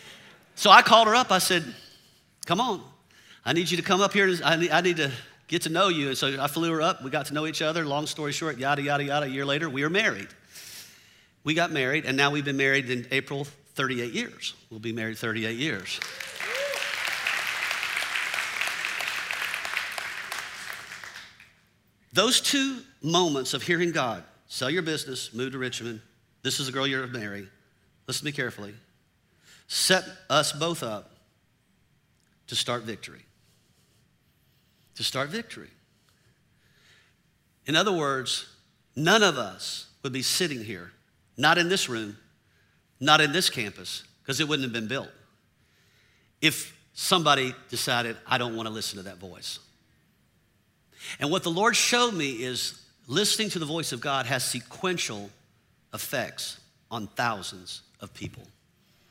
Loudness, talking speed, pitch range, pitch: -26 LUFS, 155 wpm, 120-165 Hz, 135 Hz